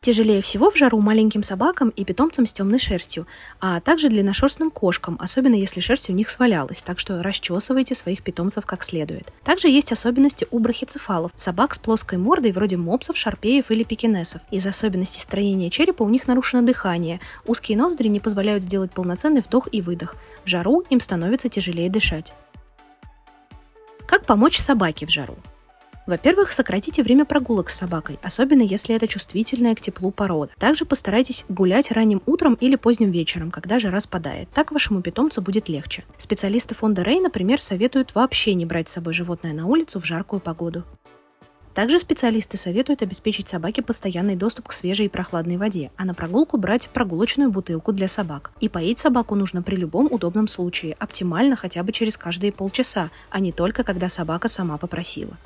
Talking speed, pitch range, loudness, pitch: 170 wpm, 180-250 Hz, -20 LUFS, 210 Hz